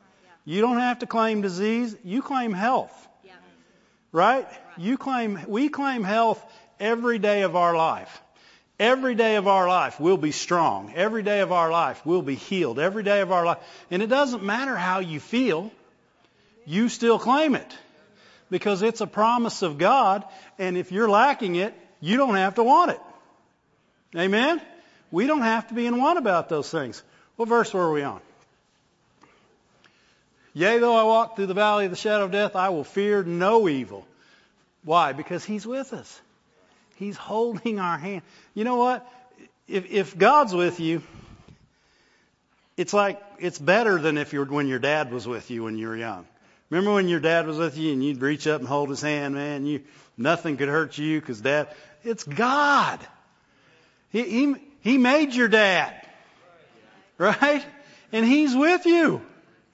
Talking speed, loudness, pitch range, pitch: 175 wpm, -23 LUFS, 170-235 Hz, 205 Hz